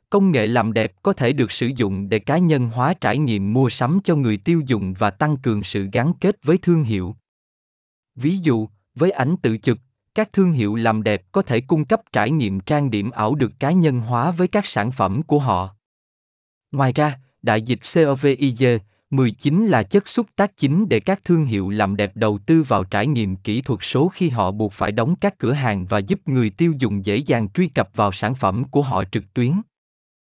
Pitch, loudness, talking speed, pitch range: 125 Hz, -20 LUFS, 215 wpm, 105-160 Hz